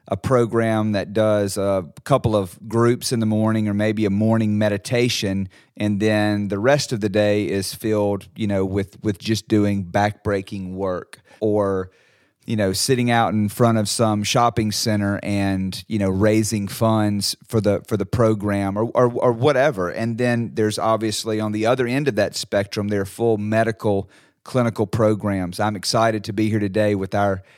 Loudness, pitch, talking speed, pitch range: -21 LUFS, 105 Hz, 180 wpm, 100-115 Hz